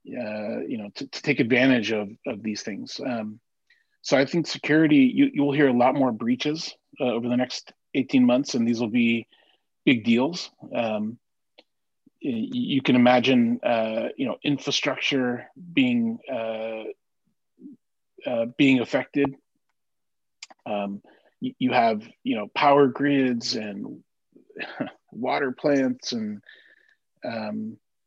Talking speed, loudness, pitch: 130 wpm, -24 LUFS, 140 Hz